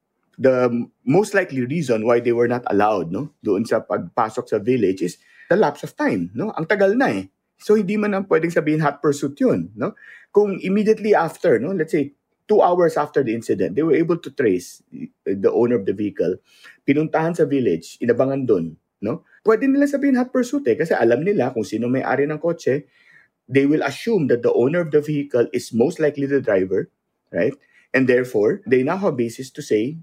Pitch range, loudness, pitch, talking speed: 125-195 Hz, -20 LUFS, 145 Hz, 200 wpm